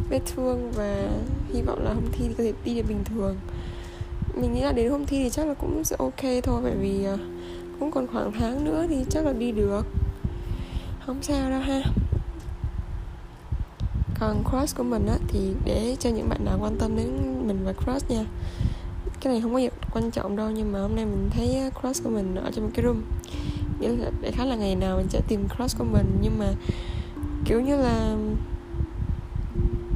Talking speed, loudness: 205 wpm, -27 LUFS